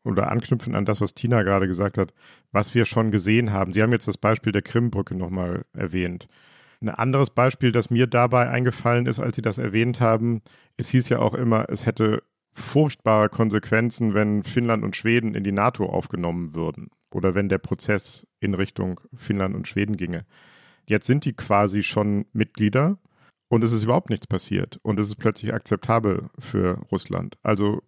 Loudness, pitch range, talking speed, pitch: -23 LUFS, 100-120 Hz, 180 wpm, 110 Hz